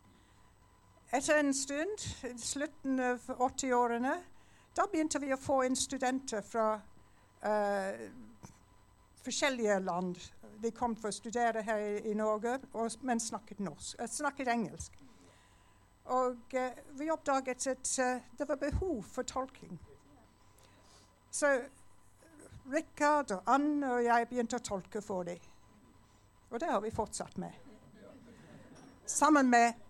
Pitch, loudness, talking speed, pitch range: 240 Hz, -34 LUFS, 125 wpm, 200-270 Hz